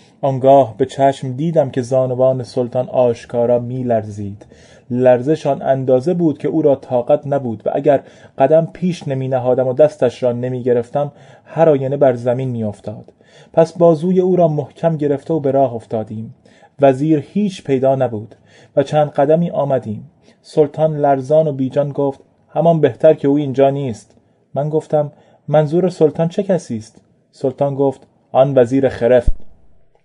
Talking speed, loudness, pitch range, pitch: 150 wpm, -16 LUFS, 125-155 Hz, 135 Hz